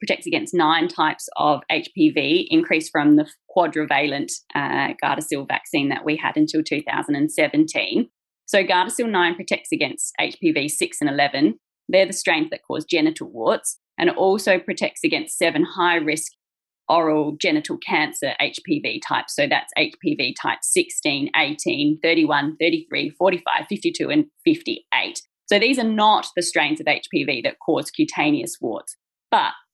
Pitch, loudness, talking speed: 225 Hz, -20 LUFS, 145 wpm